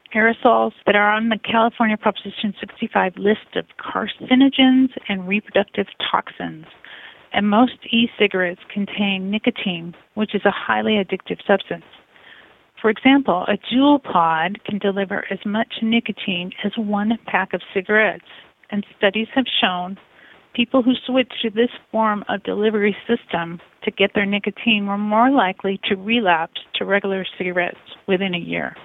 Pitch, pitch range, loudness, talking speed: 210 Hz, 195-230 Hz, -19 LUFS, 140 wpm